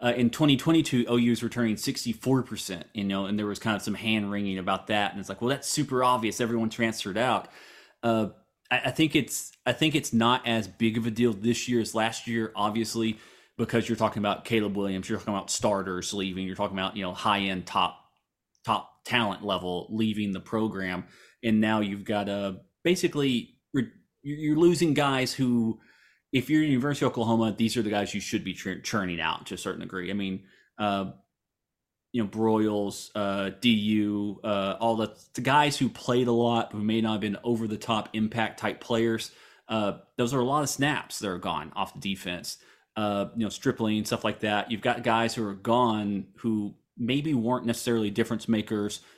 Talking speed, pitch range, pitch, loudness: 200 wpm, 100-120 Hz, 110 Hz, -28 LUFS